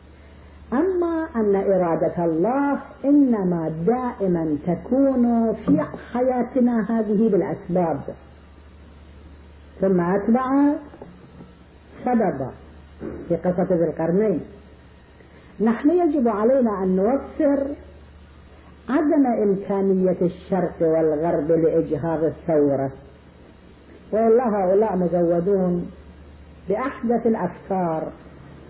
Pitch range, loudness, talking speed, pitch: 155-235 Hz, -21 LUFS, 70 wpm, 185 Hz